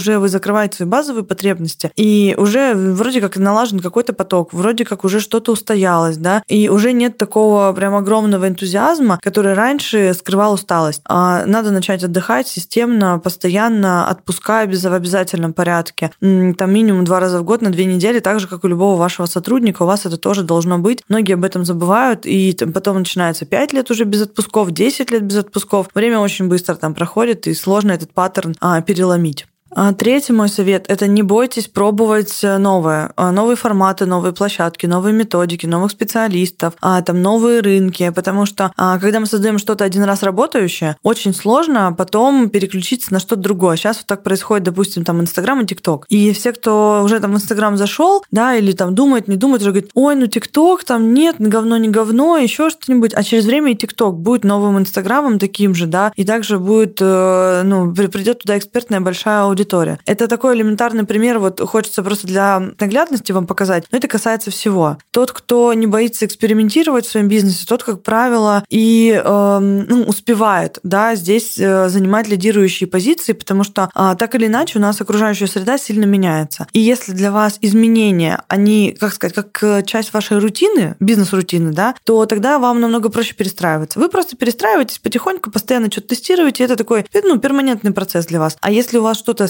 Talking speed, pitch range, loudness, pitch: 180 wpm, 190-225 Hz, -14 LUFS, 205 Hz